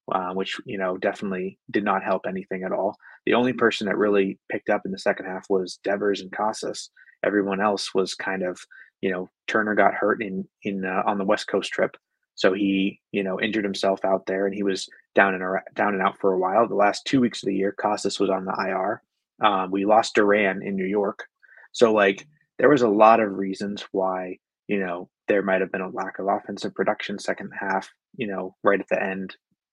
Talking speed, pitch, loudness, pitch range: 220 wpm, 95 Hz, -24 LUFS, 95-100 Hz